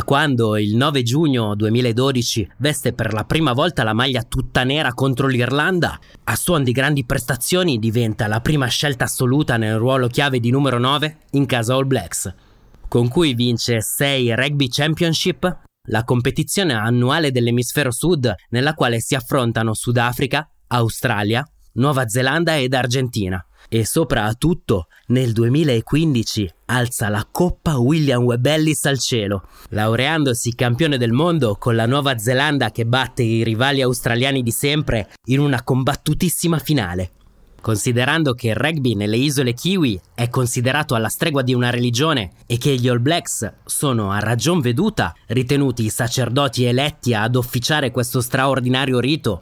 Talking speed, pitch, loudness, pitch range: 145 wpm, 125 Hz, -18 LUFS, 115-145 Hz